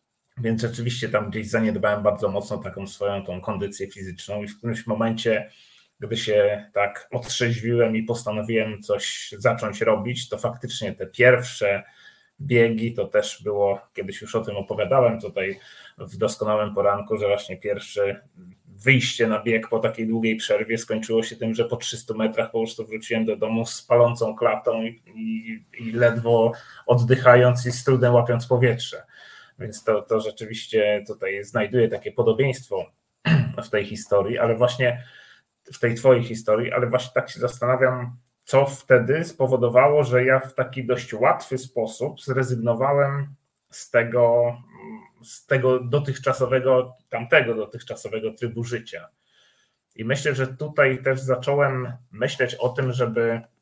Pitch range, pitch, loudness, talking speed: 110-130 Hz, 120 Hz, -22 LUFS, 145 wpm